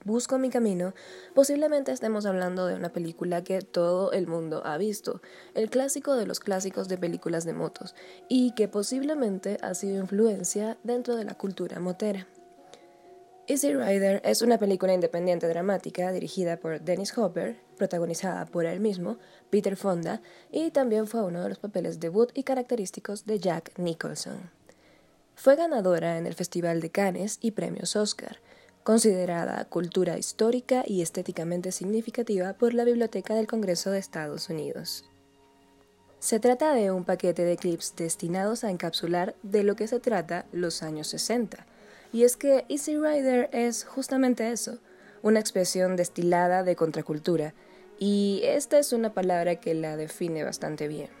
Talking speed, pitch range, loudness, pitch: 150 wpm, 175-230 Hz, -28 LUFS, 195 Hz